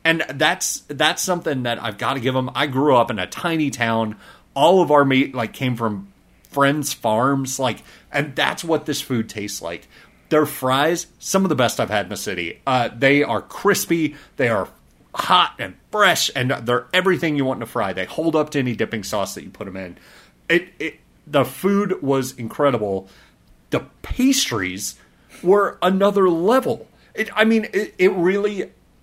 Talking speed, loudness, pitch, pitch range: 190 wpm, -20 LUFS, 140 Hz, 115-175 Hz